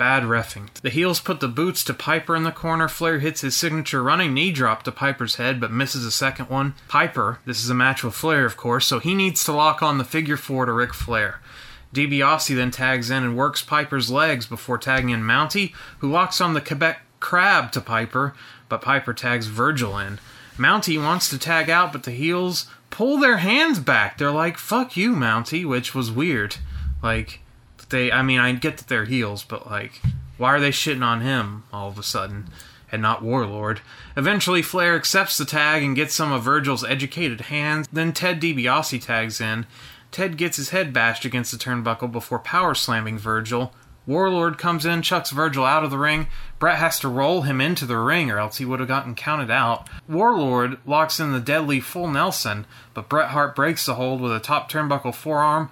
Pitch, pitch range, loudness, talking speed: 135 Hz, 120-160 Hz, -21 LUFS, 205 wpm